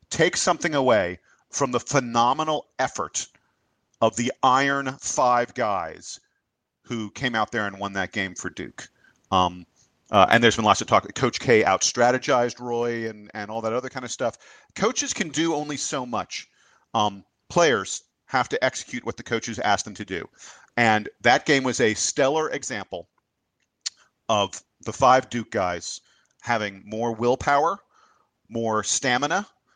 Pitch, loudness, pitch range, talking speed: 120 Hz, -23 LUFS, 110-130 Hz, 160 wpm